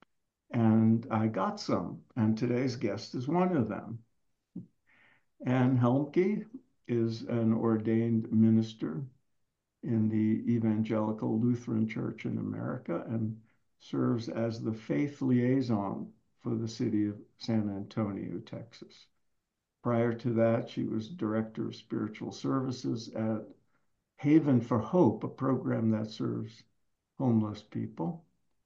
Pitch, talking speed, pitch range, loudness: 115 Hz, 115 wpm, 110-125 Hz, -31 LUFS